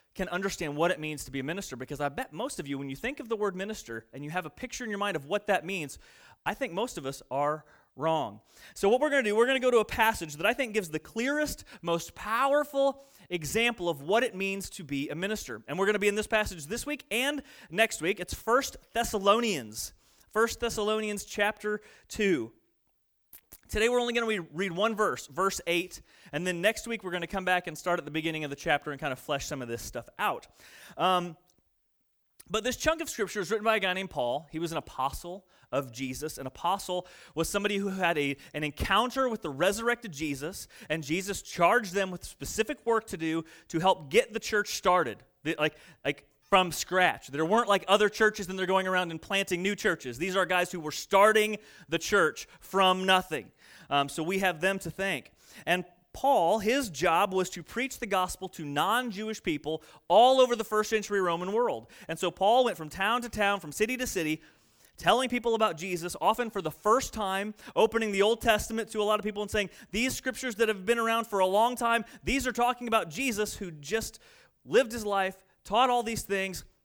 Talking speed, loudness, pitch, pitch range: 225 wpm, -29 LUFS, 195 Hz, 165-225 Hz